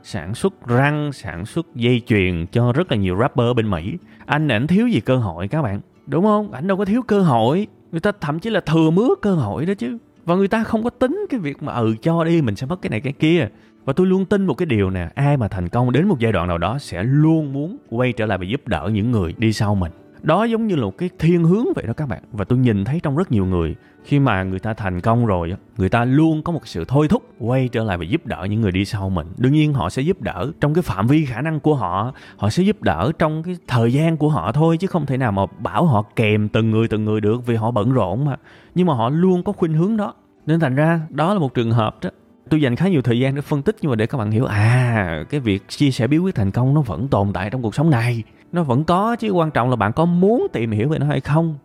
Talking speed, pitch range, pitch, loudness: 285 wpm, 110-165 Hz, 130 Hz, -19 LUFS